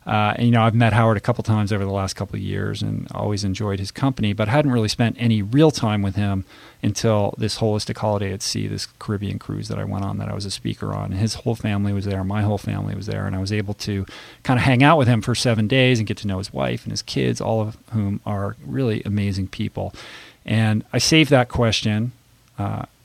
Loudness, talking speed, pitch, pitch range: -21 LUFS, 250 wpm, 105 Hz, 100-120 Hz